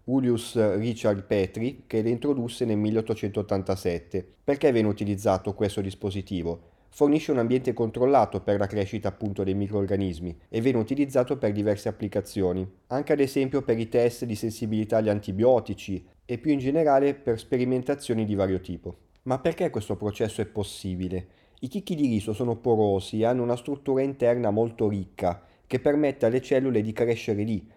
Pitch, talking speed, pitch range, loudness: 110 Hz, 160 wpm, 100-125 Hz, -26 LUFS